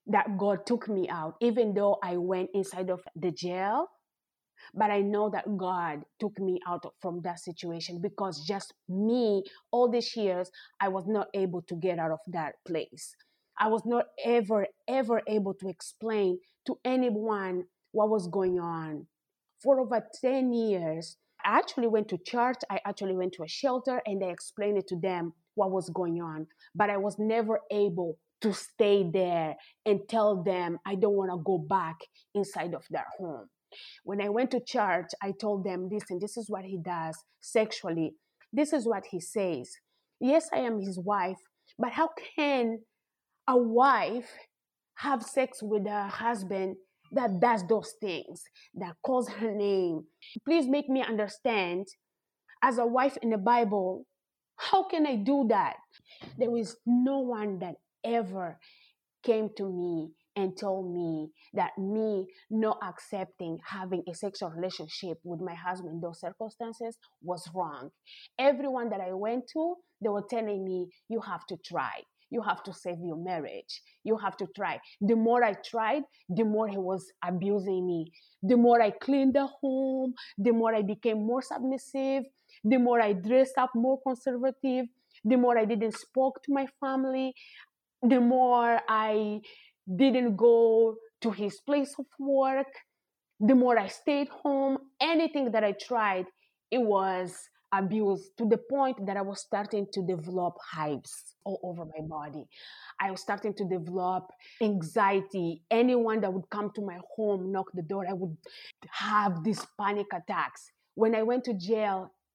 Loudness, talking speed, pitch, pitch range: -30 LUFS, 165 wpm, 210 Hz, 185-245 Hz